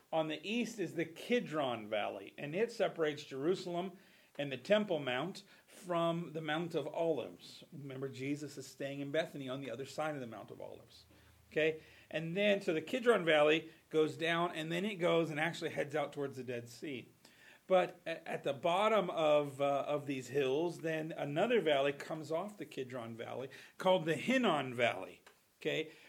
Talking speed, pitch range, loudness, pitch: 180 wpm, 140-175 Hz, -36 LUFS, 155 Hz